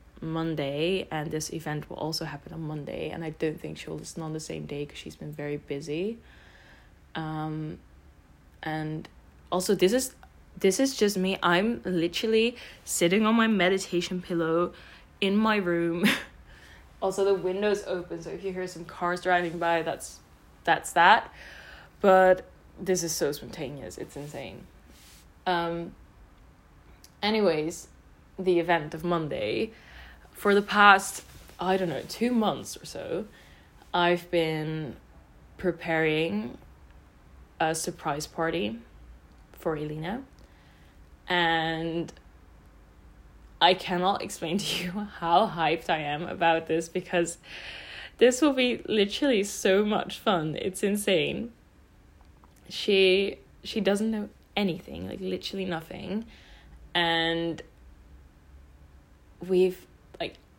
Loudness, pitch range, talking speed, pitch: -27 LUFS, 145-190 Hz, 120 wpm, 170 Hz